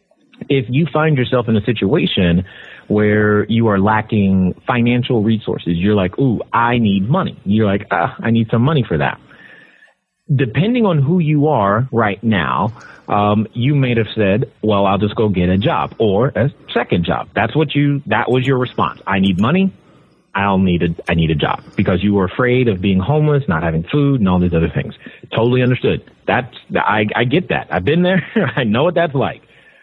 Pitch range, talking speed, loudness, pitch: 100-135 Hz, 195 wpm, -16 LUFS, 115 Hz